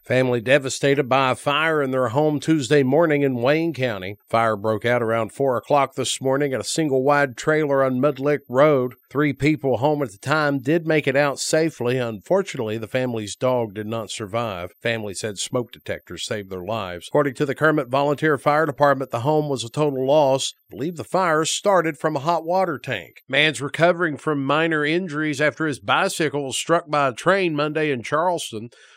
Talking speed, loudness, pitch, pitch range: 195 wpm, -21 LUFS, 140 Hz, 125-155 Hz